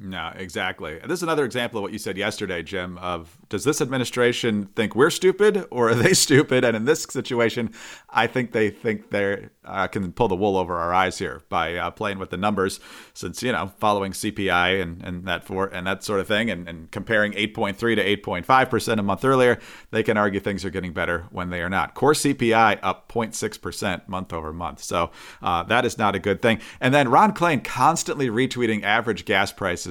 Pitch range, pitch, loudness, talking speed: 95-120 Hz, 105 Hz, -22 LUFS, 225 wpm